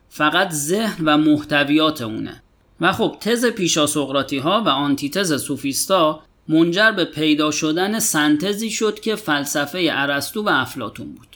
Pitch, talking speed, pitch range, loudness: 155 Hz, 135 wpm, 145-195 Hz, -19 LUFS